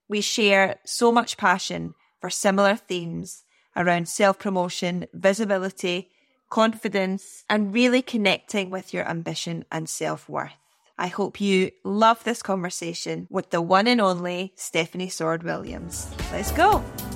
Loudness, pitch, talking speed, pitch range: -24 LUFS, 190 Hz, 135 wpm, 175-210 Hz